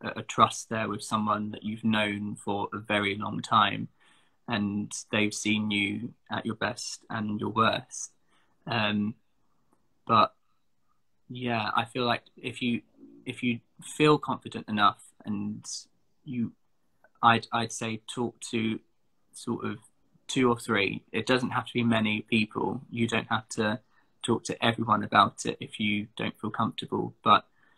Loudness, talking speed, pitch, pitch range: -28 LUFS, 150 wpm, 110 Hz, 105-120 Hz